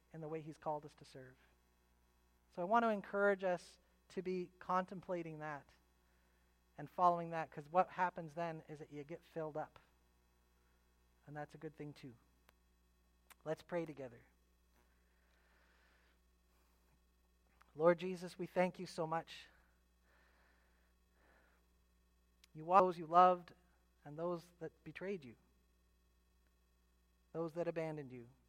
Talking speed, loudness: 125 wpm, -39 LUFS